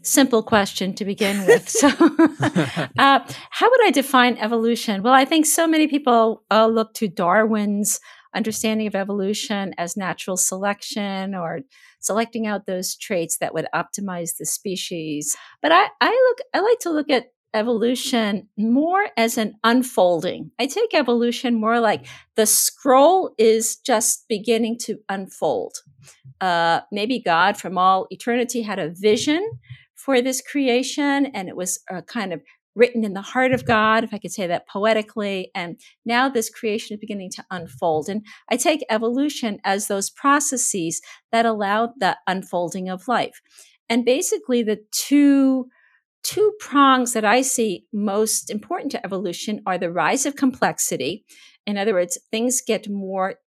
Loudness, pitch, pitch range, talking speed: -20 LUFS, 220 Hz, 195-255 Hz, 155 wpm